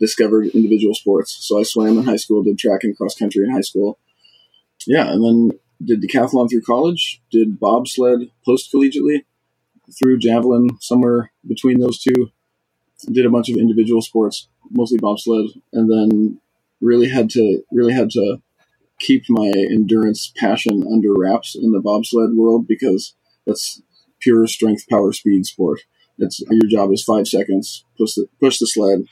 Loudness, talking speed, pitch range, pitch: -16 LUFS, 160 wpm, 105-120 Hz, 115 Hz